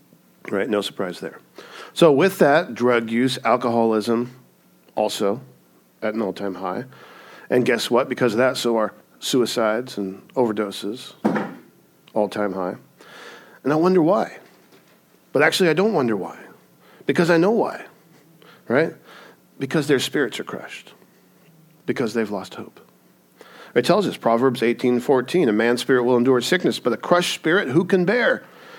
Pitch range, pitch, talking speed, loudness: 105-130 Hz, 120 Hz, 145 wpm, -21 LUFS